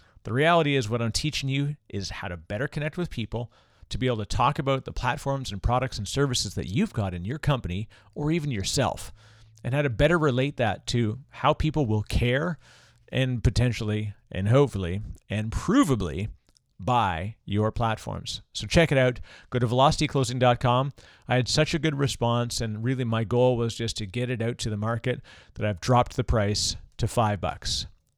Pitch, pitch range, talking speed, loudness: 120 Hz, 105-135 Hz, 190 wpm, -26 LUFS